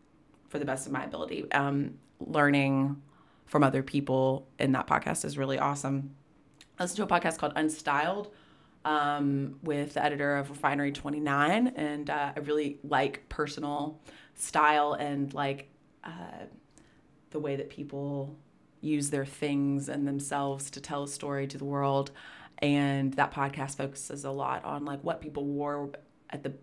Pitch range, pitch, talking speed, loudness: 140-150 Hz, 145 Hz, 160 wpm, -31 LUFS